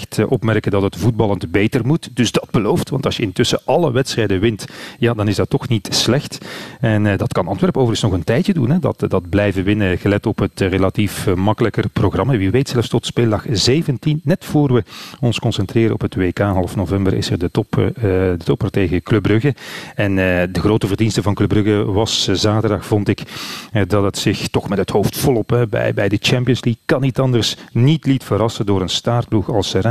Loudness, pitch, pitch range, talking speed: -17 LUFS, 110 Hz, 100-125 Hz, 225 wpm